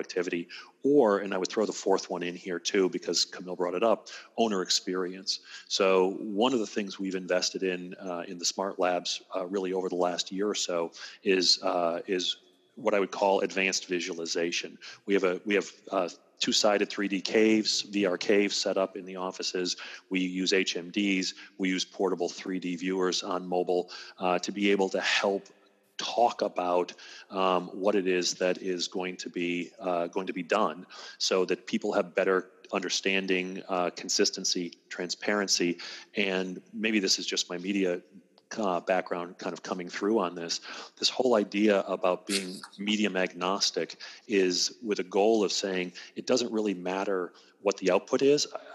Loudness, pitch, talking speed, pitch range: -29 LUFS, 95 Hz, 180 wpm, 90-100 Hz